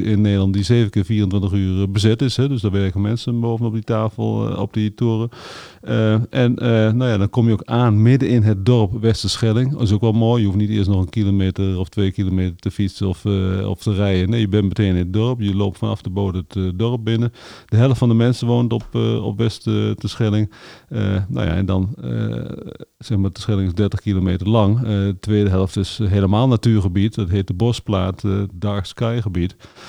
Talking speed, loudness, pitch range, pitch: 225 wpm, -19 LUFS, 100-115 Hz, 105 Hz